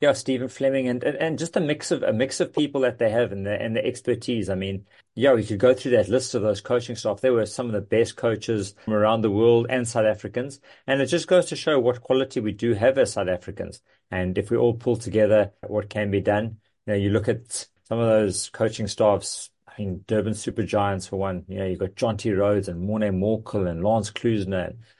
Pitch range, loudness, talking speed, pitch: 100-125 Hz, -24 LUFS, 250 wpm, 110 Hz